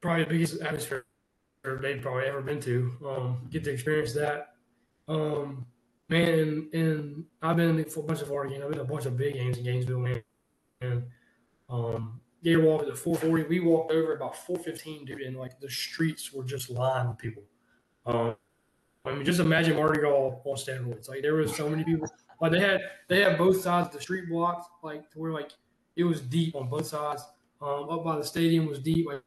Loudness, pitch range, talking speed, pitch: -29 LUFS, 130-160 Hz, 210 wpm, 150 Hz